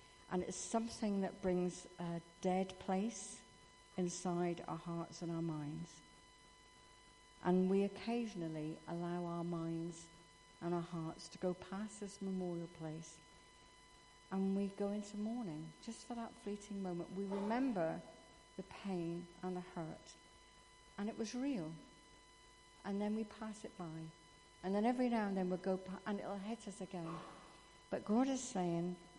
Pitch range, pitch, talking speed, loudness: 170-205 Hz, 185 Hz, 155 wpm, -43 LUFS